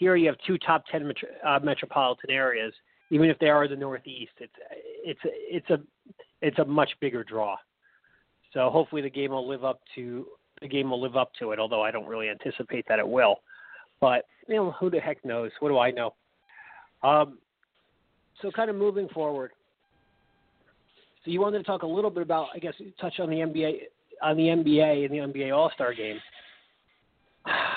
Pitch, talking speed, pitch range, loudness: 150 Hz, 190 wpm, 130-185 Hz, -27 LUFS